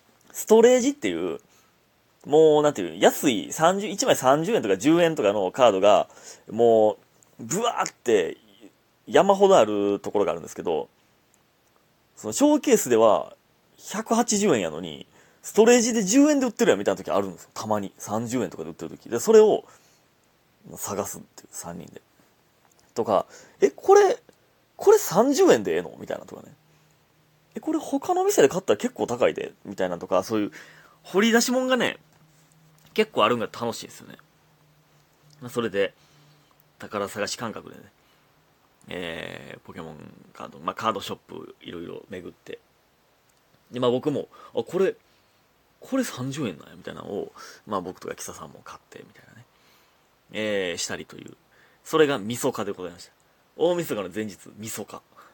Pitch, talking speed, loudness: 205 Hz, 315 characters per minute, -23 LUFS